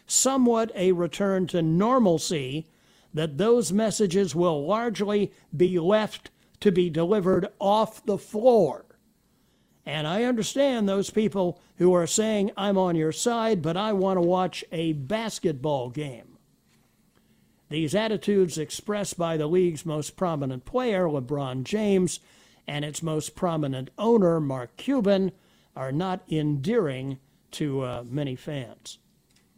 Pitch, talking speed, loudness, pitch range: 180 Hz, 130 wpm, -25 LUFS, 155-210 Hz